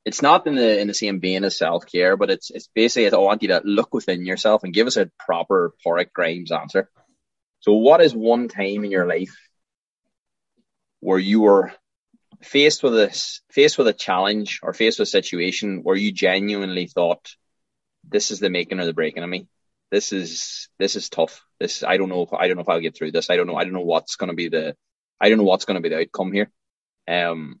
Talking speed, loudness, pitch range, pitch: 230 wpm, -20 LUFS, 95-110 Hz, 100 Hz